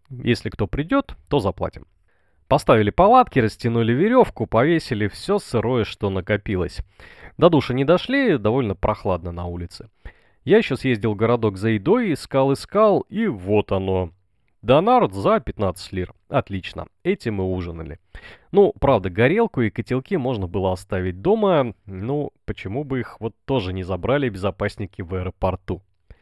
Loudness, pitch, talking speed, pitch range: -21 LUFS, 110 Hz, 140 wpm, 95-135 Hz